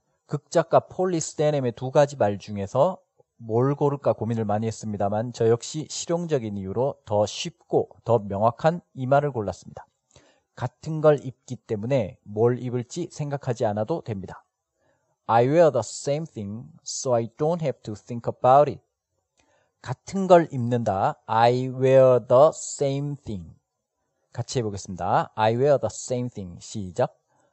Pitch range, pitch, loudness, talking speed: 110-145 Hz, 125 Hz, -24 LUFS, 370 characters per minute